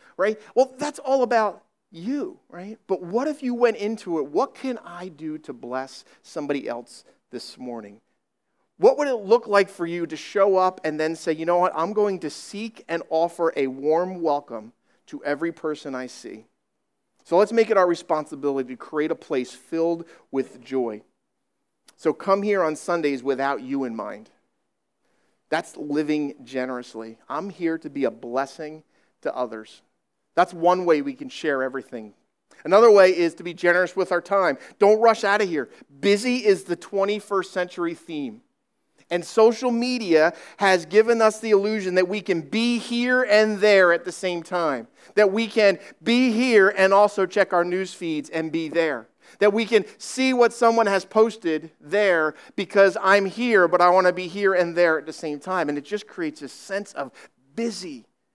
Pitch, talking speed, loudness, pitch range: 180 Hz, 185 wpm, -22 LUFS, 155-215 Hz